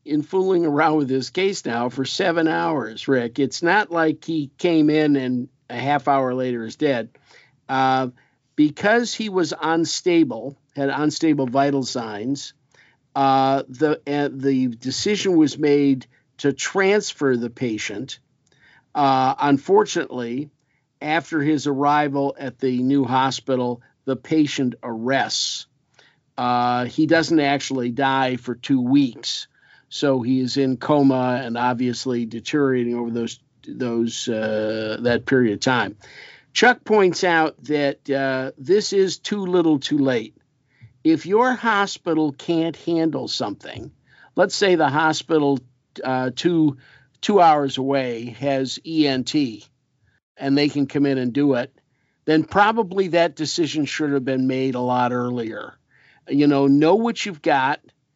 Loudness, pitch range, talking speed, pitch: -21 LUFS, 130-160 Hz, 135 wpm, 140 Hz